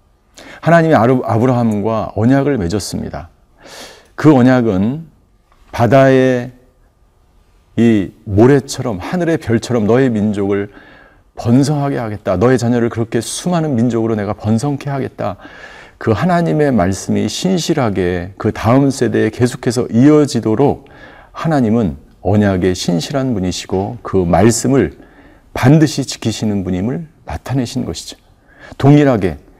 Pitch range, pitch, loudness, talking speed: 105-135 Hz, 120 Hz, -14 LUFS, 275 characters per minute